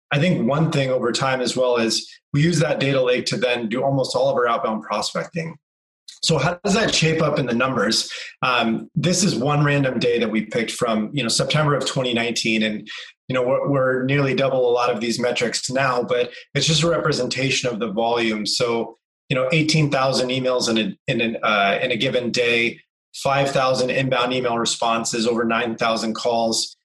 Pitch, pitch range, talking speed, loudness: 130 Hz, 120-150 Hz, 210 wpm, -20 LUFS